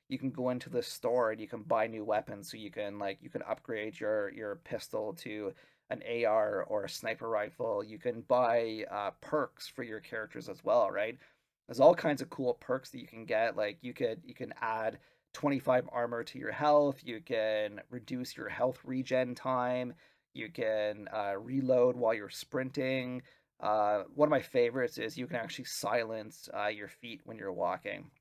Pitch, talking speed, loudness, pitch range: 125 Hz, 195 wpm, -34 LUFS, 110-130 Hz